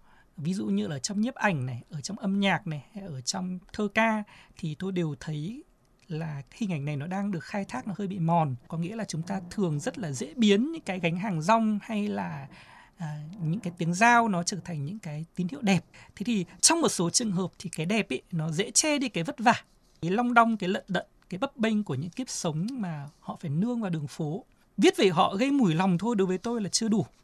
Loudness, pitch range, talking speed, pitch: -28 LUFS, 165-220 Hz, 255 wpm, 190 Hz